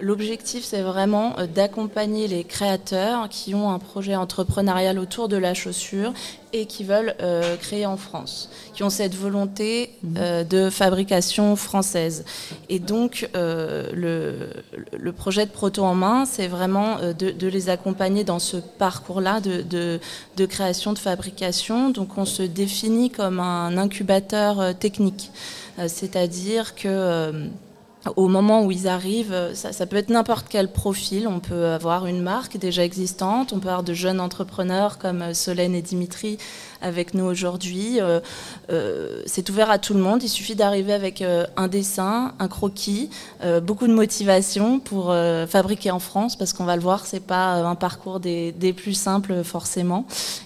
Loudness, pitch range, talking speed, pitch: -23 LUFS, 180-205 Hz, 165 wpm, 190 Hz